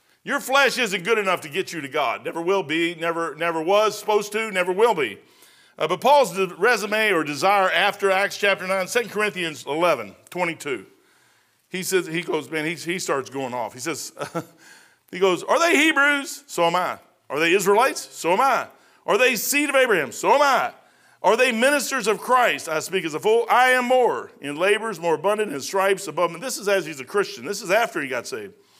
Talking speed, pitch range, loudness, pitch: 215 wpm, 170-240 Hz, -21 LUFS, 195 Hz